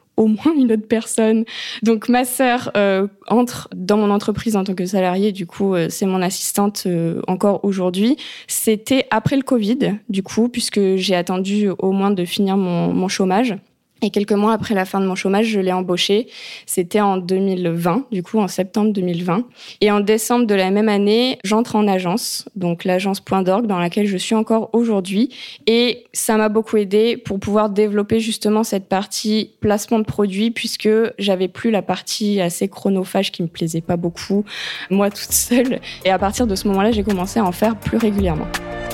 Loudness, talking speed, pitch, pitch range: -18 LUFS, 190 wpm, 205 Hz, 190-220 Hz